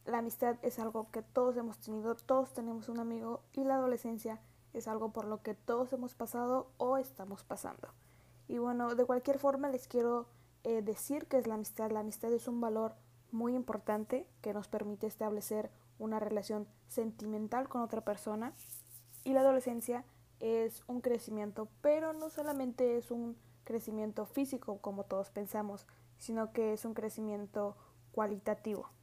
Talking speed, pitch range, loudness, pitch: 160 wpm, 210-245 Hz, -38 LUFS, 225 Hz